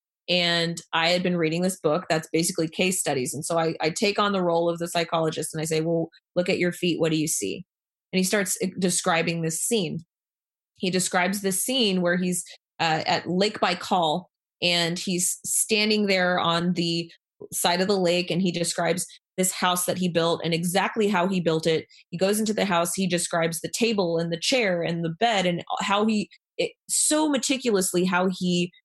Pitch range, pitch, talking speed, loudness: 165-190 Hz, 175 Hz, 205 wpm, -24 LUFS